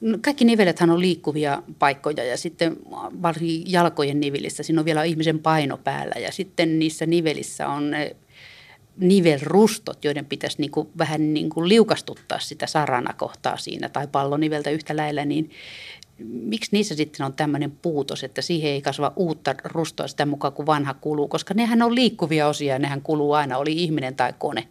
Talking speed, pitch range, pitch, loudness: 170 wpm, 145-170 Hz, 155 Hz, -23 LUFS